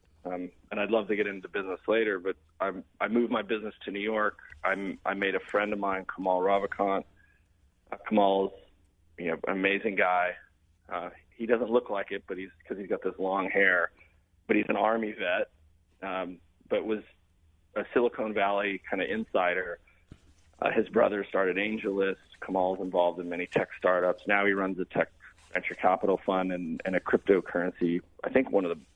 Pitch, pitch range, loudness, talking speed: 95 Hz, 85-100 Hz, -29 LUFS, 185 wpm